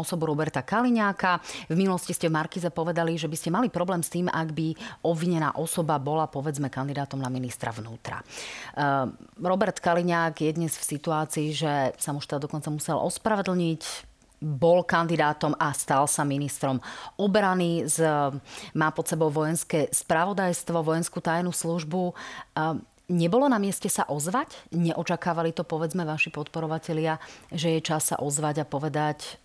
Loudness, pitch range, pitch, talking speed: -26 LUFS, 150-175 Hz, 165 Hz, 145 wpm